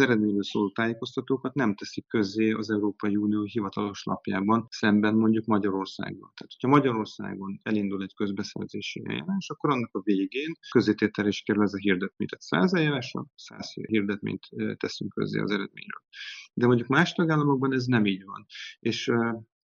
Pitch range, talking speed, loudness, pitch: 105-125 Hz, 150 wpm, -27 LUFS, 110 Hz